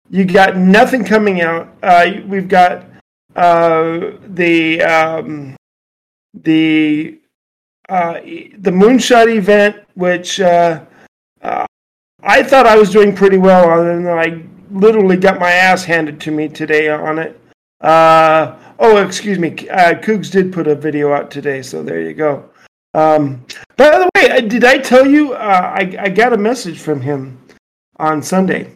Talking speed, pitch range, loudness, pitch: 150 wpm, 160-205 Hz, -11 LUFS, 180 Hz